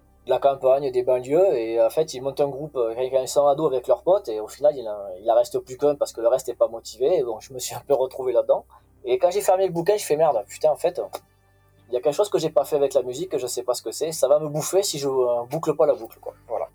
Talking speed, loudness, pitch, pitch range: 305 wpm, -23 LUFS, 150 Hz, 130-205 Hz